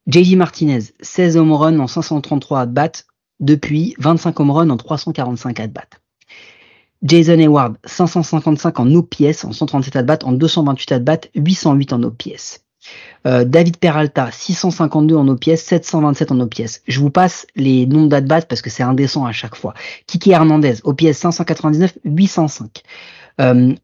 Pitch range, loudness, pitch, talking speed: 130-165 Hz, -14 LUFS, 155 Hz, 145 wpm